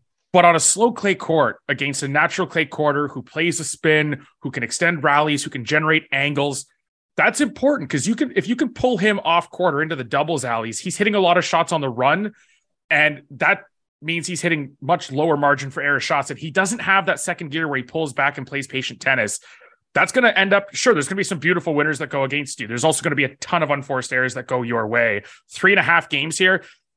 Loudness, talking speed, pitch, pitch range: -19 LUFS, 245 wpm, 155 Hz, 140-180 Hz